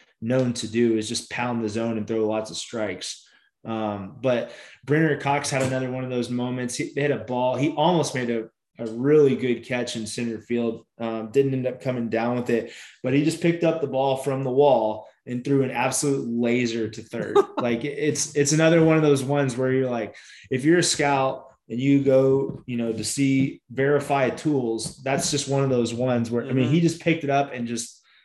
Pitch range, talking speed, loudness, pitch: 115-140 Hz, 220 wpm, -23 LUFS, 130 Hz